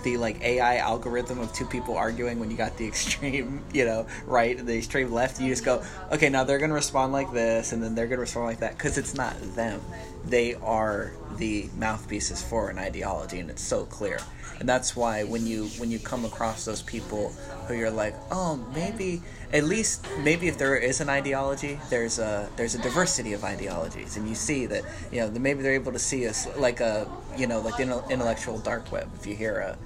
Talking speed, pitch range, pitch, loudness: 220 wpm, 110-135 Hz, 120 Hz, -28 LUFS